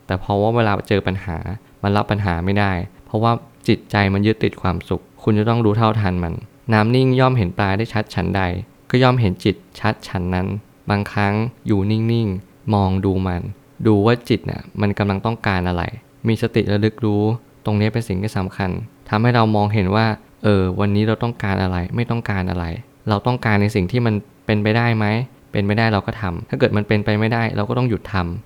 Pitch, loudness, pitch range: 105 Hz, -19 LUFS, 95-115 Hz